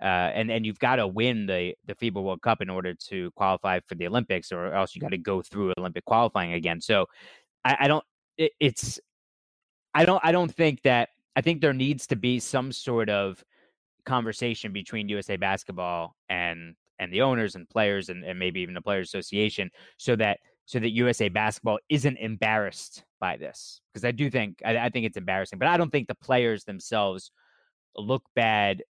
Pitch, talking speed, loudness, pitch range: 110 Hz, 195 wpm, -27 LUFS, 95-130 Hz